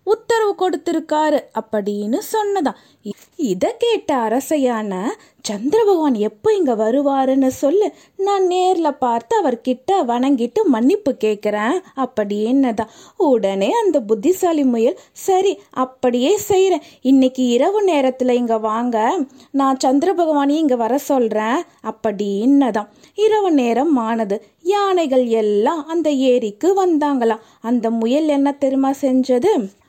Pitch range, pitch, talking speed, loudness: 230-345 Hz, 270 Hz, 105 wpm, -17 LUFS